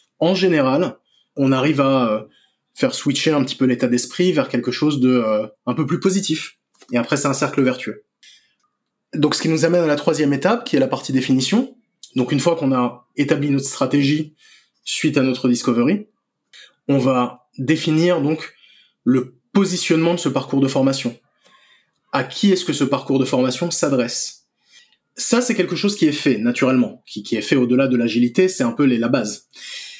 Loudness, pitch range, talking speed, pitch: -19 LUFS, 130-175 Hz, 185 wpm, 145 Hz